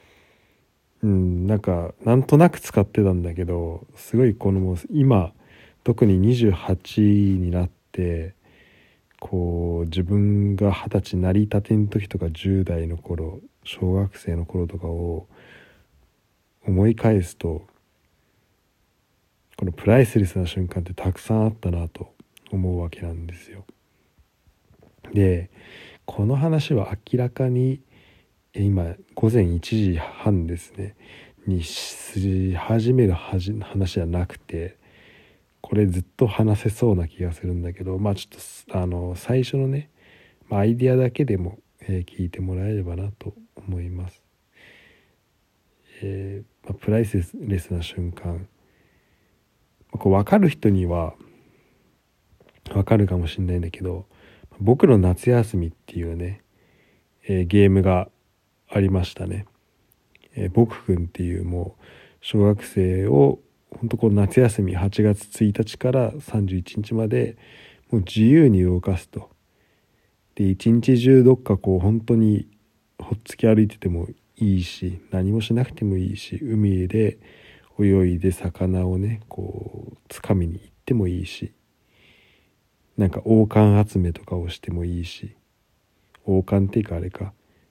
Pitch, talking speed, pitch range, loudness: 100 Hz, 235 characters per minute, 90-110 Hz, -22 LUFS